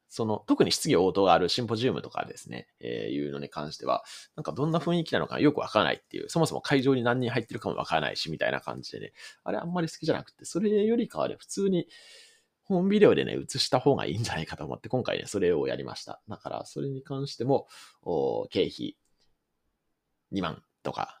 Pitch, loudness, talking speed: 160 Hz, -28 LUFS, 440 characters per minute